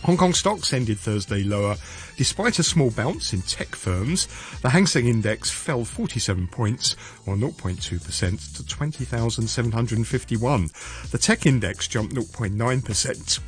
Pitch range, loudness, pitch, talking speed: 100-130 Hz, -23 LUFS, 115 Hz, 130 wpm